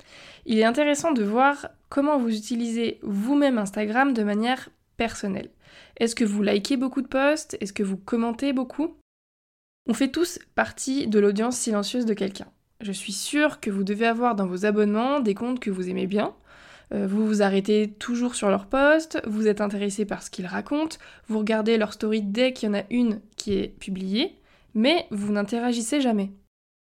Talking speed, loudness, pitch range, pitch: 180 wpm, -25 LUFS, 205-265 Hz, 225 Hz